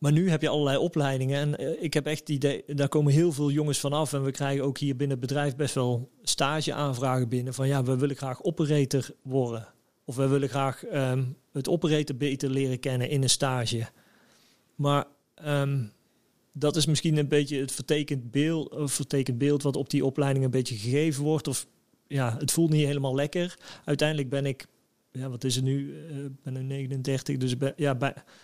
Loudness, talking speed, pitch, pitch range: -28 LUFS, 200 wpm, 140 Hz, 135-150 Hz